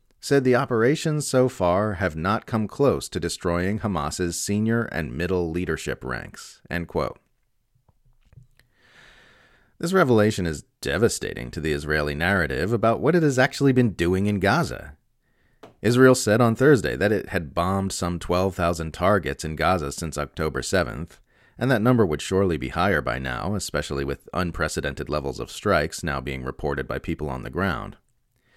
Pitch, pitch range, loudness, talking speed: 95 Hz, 80-115 Hz, -23 LUFS, 160 wpm